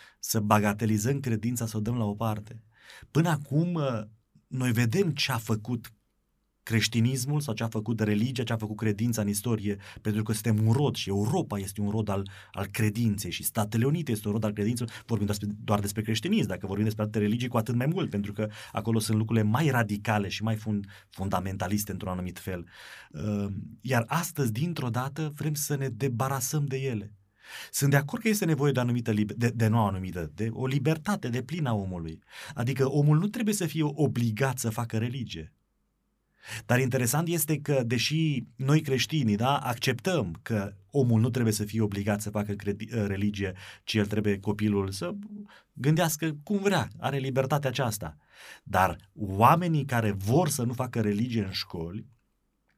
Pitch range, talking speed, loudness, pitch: 105-135 Hz, 180 wpm, -28 LUFS, 115 Hz